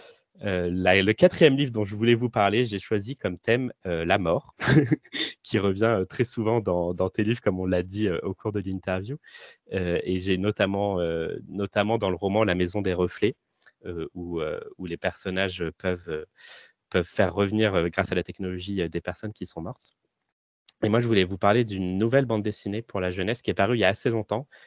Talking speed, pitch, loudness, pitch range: 220 wpm, 100 Hz, -26 LUFS, 90-110 Hz